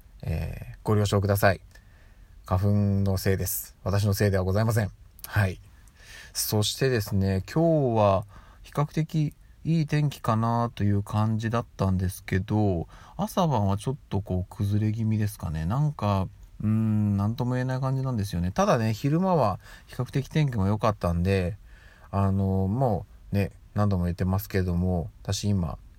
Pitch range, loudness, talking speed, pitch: 95-115 Hz, -27 LUFS, 315 characters per minute, 100 Hz